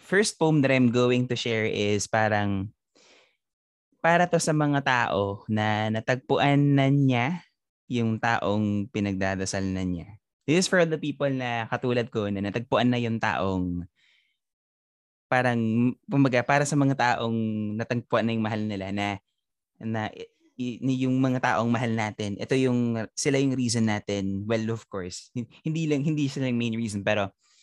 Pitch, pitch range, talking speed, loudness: 115 Hz, 105-135 Hz, 160 wpm, -26 LUFS